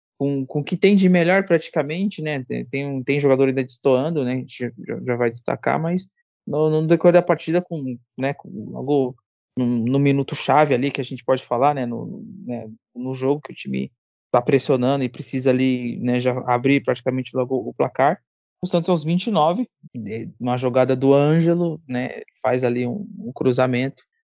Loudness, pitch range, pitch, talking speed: -21 LUFS, 125-165 Hz, 135 Hz, 175 wpm